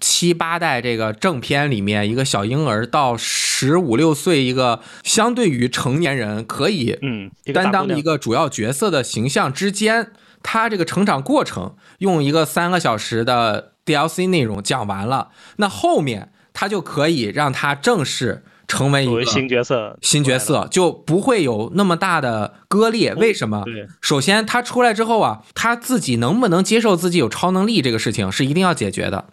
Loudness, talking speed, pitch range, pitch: -18 LUFS, 270 characters per minute, 120-195 Hz, 160 Hz